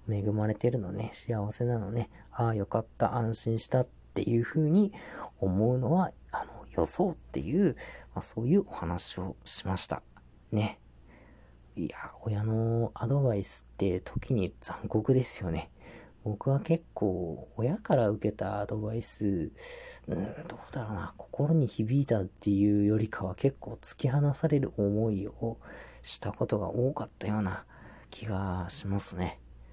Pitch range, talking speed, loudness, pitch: 100-125 Hz, 280 characters per minute, -31 LUFS, 110 Hz